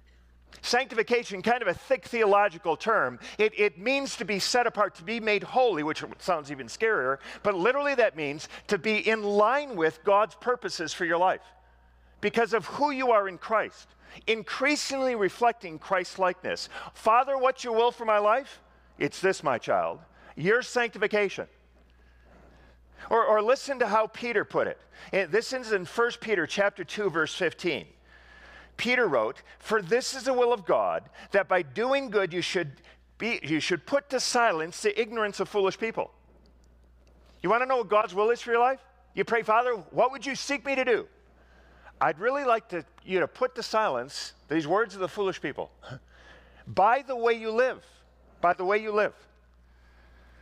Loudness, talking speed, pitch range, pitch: -27 LUFS, 180 wpm, 175-245 Hz, 215 Hz